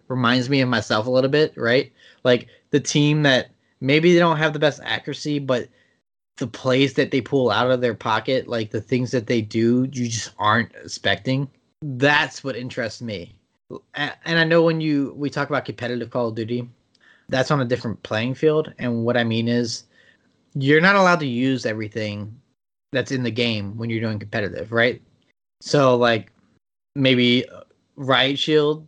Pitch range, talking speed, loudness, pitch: 115-140 Hz, 180 wpm, -21 LUFS, 130 Hz